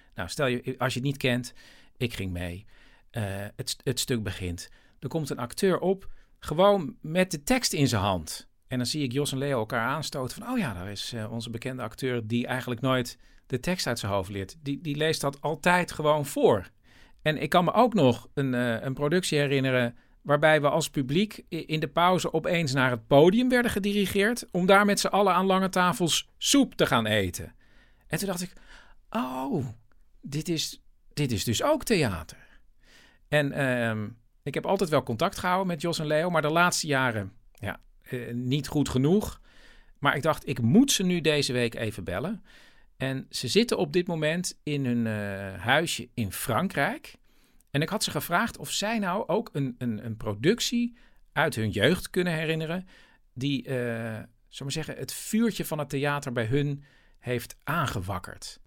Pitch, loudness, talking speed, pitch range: 140 Hz, -27 LUFS, 190 wpm, 120-175 Hz